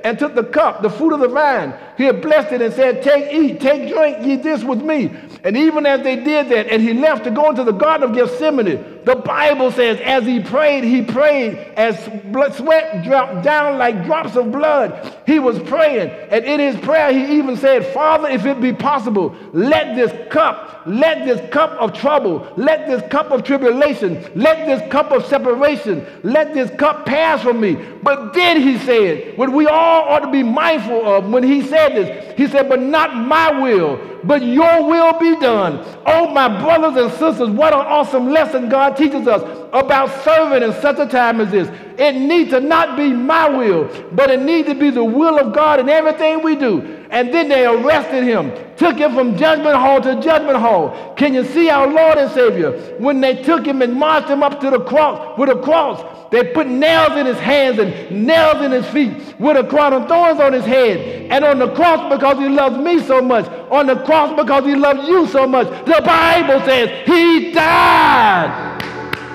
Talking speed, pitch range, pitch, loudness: 205 wpm, 255-310 Hz, 280 Hz, -14 LUFS